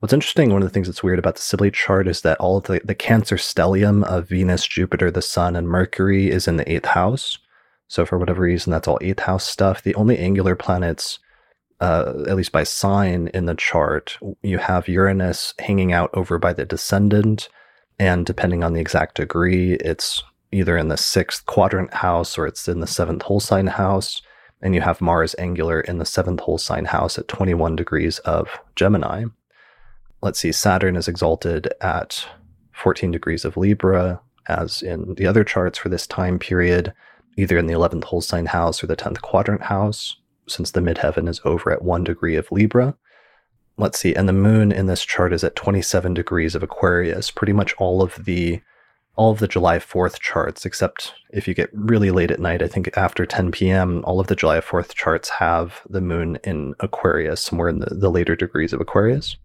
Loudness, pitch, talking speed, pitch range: -20 LUFS, 90 Hz, 200 wpm, 85-100 Hz